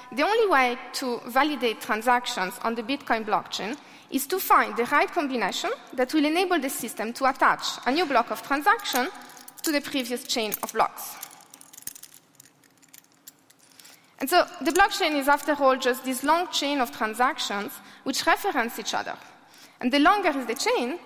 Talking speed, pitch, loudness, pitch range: 160 wpm, 270 Hz, -25 LUFS, 245-335 Hz